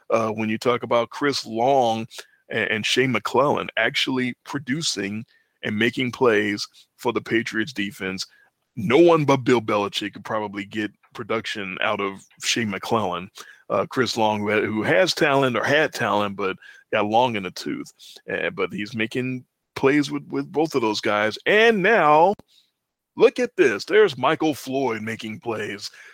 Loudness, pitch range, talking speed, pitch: -22 LUFS, 105-140 Hz, 160 wpm, 120 Hz